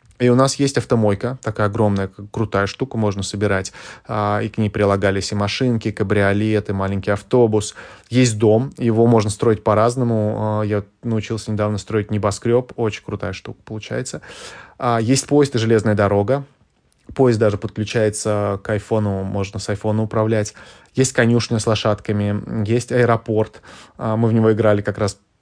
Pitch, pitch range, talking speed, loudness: 110 Hz, 105-115 Hz, 150 wpm, -19 LUFS